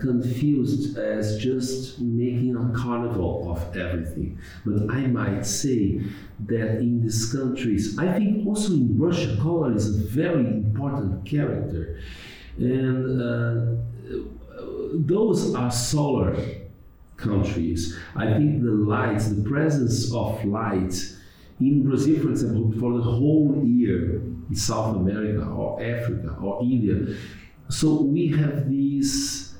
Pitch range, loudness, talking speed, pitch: 105-140 Hz, -24 LUFS, 120 wpm, 120 Hz